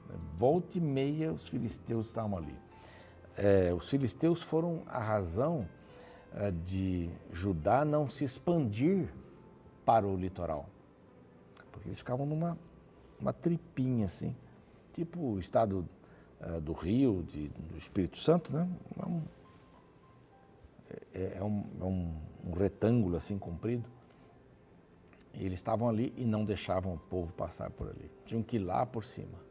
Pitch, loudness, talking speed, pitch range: 110 Hz, -34 LUFS, 135 wpm, 95-140 Hz